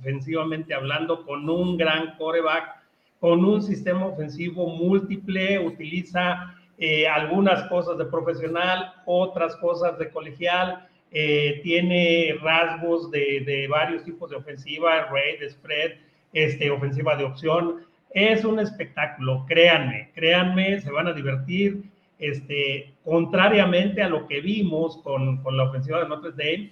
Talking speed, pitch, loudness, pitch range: 130 wpm, 165 Hz, -23 LUFS, 150-180 Hz